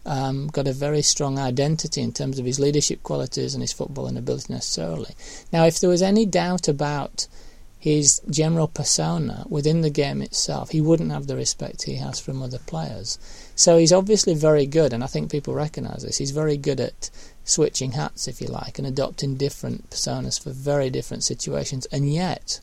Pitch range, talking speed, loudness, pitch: 135-155 Hz, 190 wpm, -22 LUFS, 145 Hz